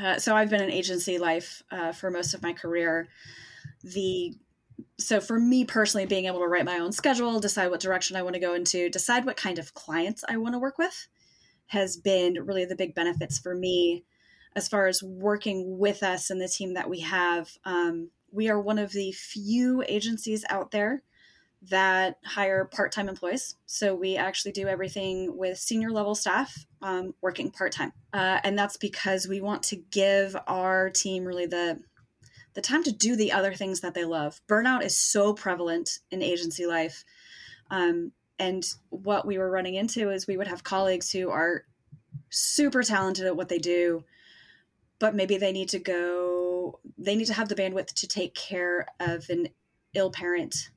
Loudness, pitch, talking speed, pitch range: -27 LUFS, 190 Hz, 185 wpm, 175-205 Hz